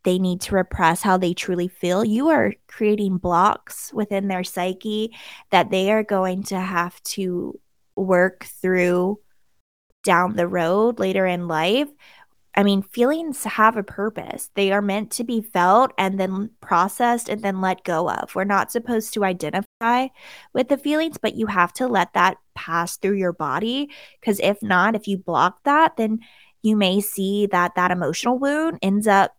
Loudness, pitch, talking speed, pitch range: -21 LUFS, 195 Hz, 175 wpm, 180-225 Hz